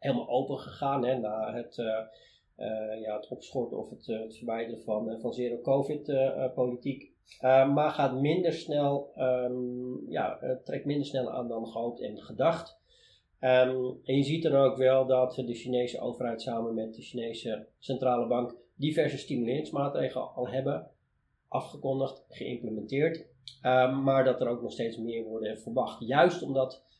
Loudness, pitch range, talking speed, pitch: -30 LUFS, 115-135 Hz, 155 wpm, 125 Hz